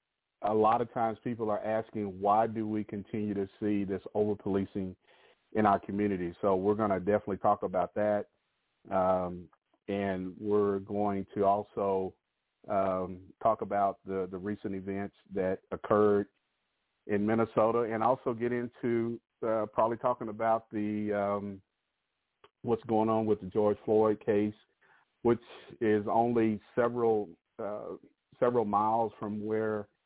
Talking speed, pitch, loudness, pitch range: 140 wpm, 105 Hz, -31 LUFS, 100-110 Hz